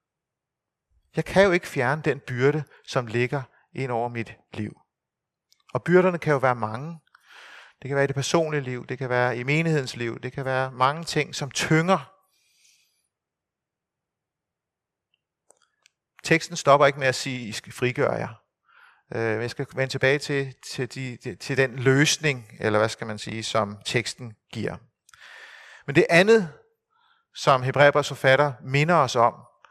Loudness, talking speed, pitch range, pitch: -23 LUFS, 160 wpm, 125-150 Hz, 135 Hz